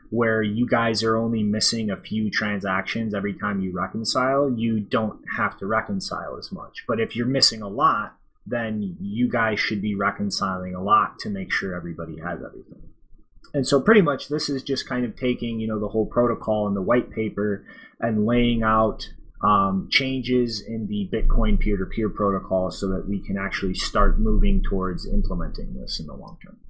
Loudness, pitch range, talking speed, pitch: -24 LUFS, 100-115 Hz, 185 wpm, 110 Hz